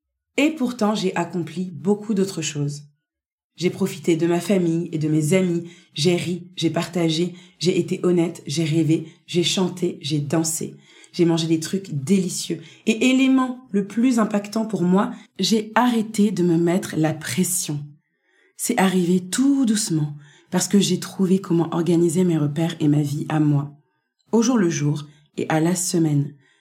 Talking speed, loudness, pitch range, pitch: 165 wpm, -21 LUFS, 160-195 Hz, 175 Hz